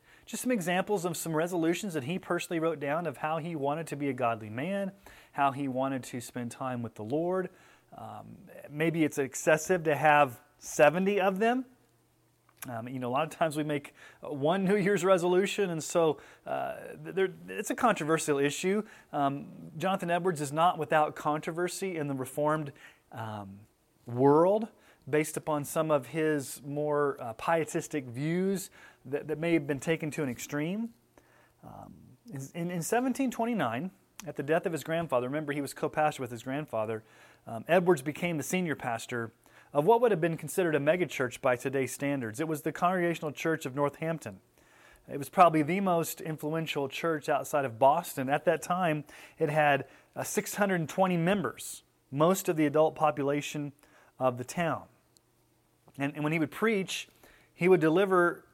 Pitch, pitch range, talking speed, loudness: 155 Hz, 140-175 Hz, 170 wpm, -30 LUFS